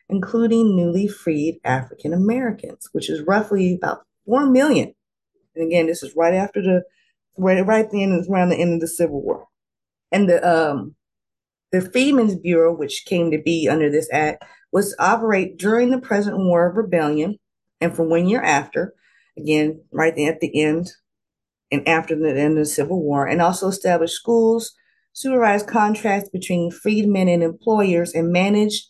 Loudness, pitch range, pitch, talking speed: -19 LUFS, 165-210 Hz, 180 Hz, 170 wpm